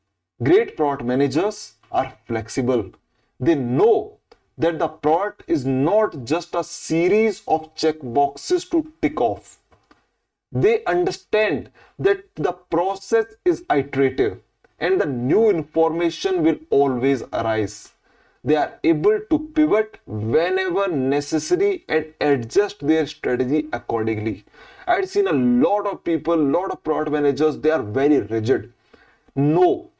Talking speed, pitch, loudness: 125 wpm, 170 Hz, -21 LUFS